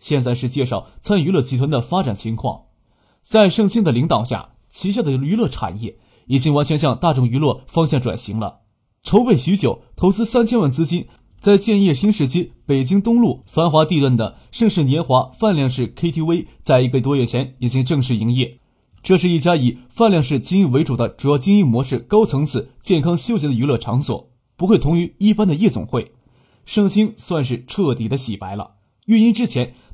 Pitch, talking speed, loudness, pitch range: 140 Hz, 295 characters per minute, -17 LUFS, 125-185 Hz